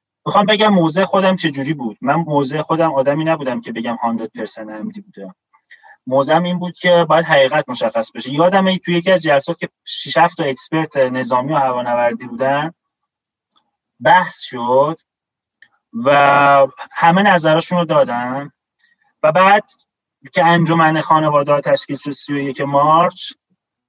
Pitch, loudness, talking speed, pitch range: 160 Hz, -15 LUFS, 140 wpm, 140-185 Hz